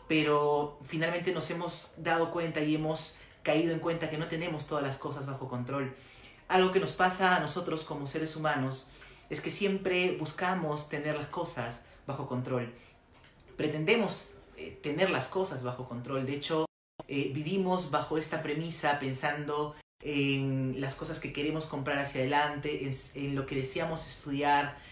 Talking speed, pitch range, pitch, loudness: 160 wpm, 140-165 Hz, 150 Hz, -32 LUFS